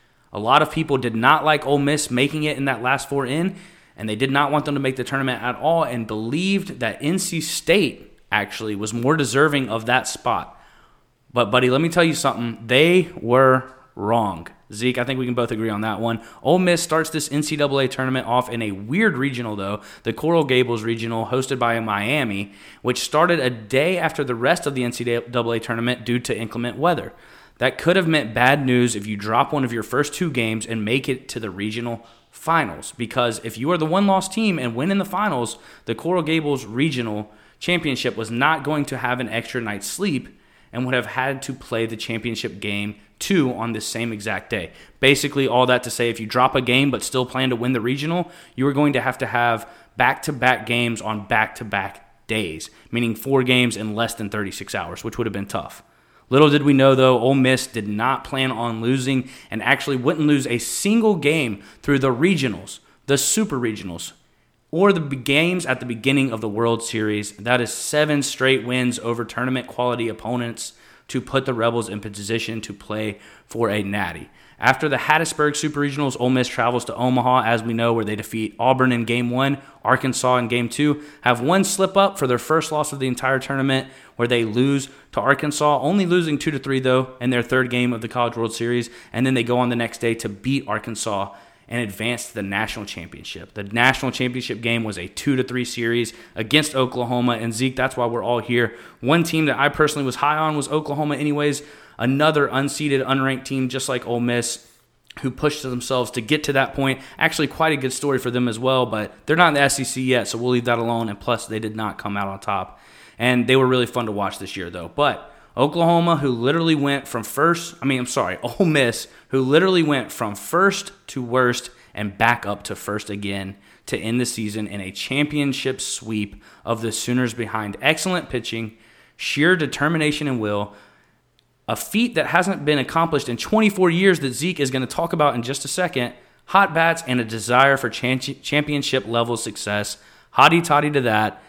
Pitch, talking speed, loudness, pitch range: 125 Hz, 210 wpm, -21 LUFS, 115-145 Hz